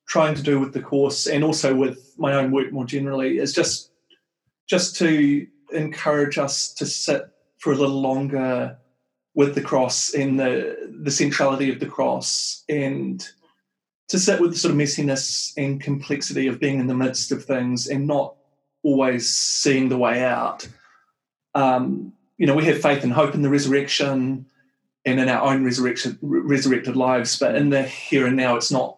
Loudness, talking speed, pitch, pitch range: -21 LUFS, 180 wpm, 140 Hz, 130-145 Hz